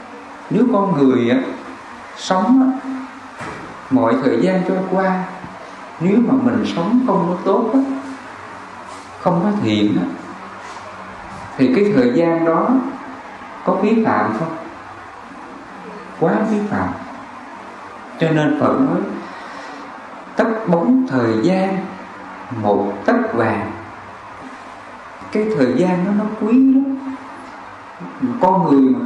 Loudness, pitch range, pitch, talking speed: -17 LUFS, 180-250 Hz, 205 Hz, 115 wpm